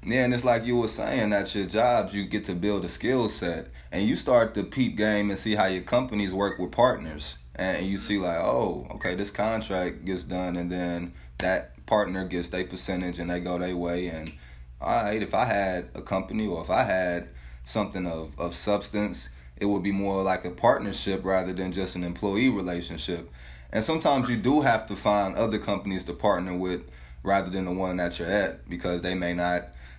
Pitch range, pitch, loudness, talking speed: 85-100 Hz, 90 Hz, -27 LUFS, 210 wpm